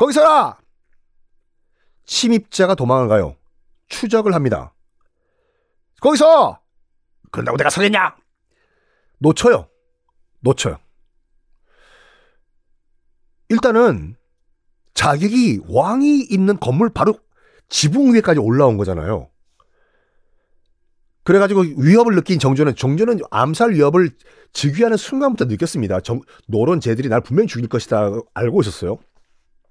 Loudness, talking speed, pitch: -16 LUFS, 240 characters per minute, 210 Hz